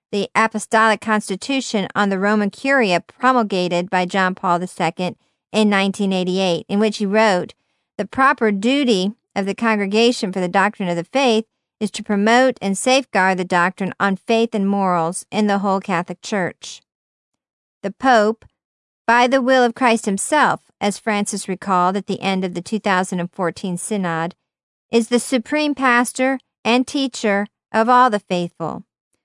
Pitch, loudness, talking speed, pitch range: 205 Hz, -18 LUFS, 150 wpm, 190-230 Hz